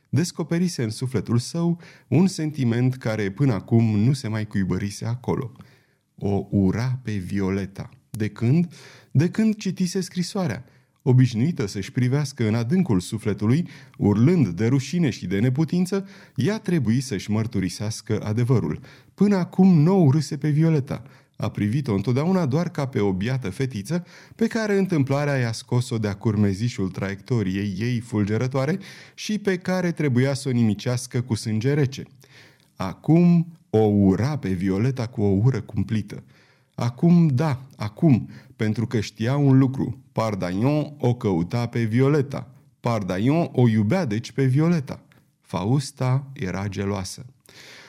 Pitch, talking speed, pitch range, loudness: 130 Hz, 135 wpm, 110-150 Hz, -23 LUFS